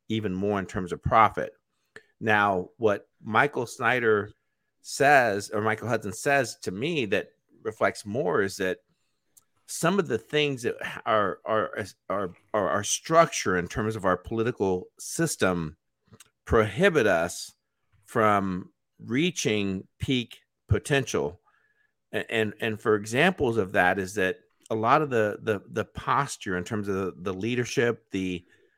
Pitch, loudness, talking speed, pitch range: 110 Hz, -26 LUFS, 145 wpm, 95-125 Hz